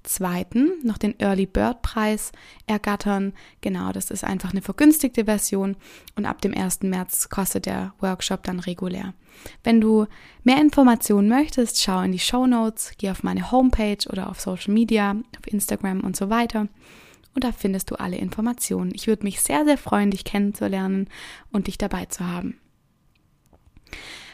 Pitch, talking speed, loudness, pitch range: 205 Hz, 165 wpm, -23 LUFS, 190-230 Hz